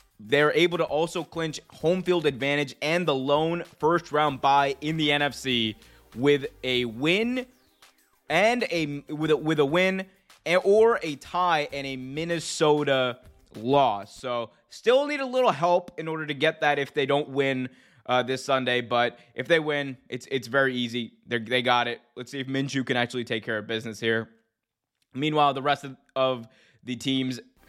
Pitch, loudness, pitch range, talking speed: 140 Hz, -25 LUFS, 125-160 Hz, 180 wpm